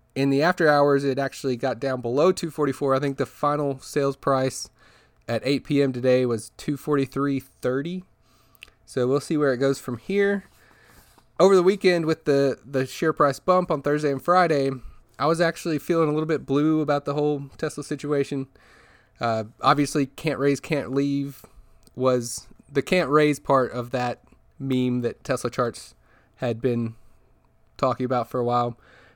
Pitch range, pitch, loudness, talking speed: 125-150 Hz, 140 Hz, -24 LUFS, 165 wpm